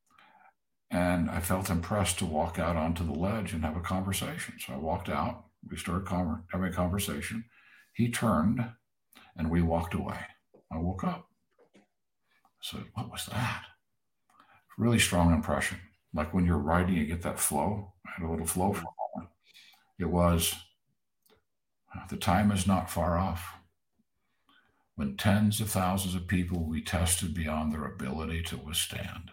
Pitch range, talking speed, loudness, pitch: 85-95 Hz, 160 wpm, -31 LUFS, 90 Hz